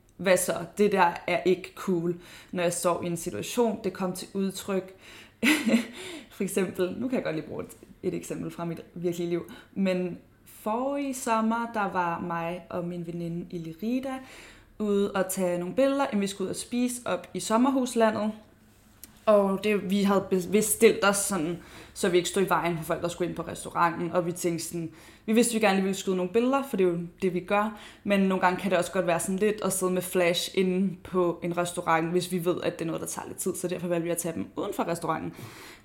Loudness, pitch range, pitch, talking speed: -28 LUFS, 175-210 Hz, 185 Hz, 225 wpm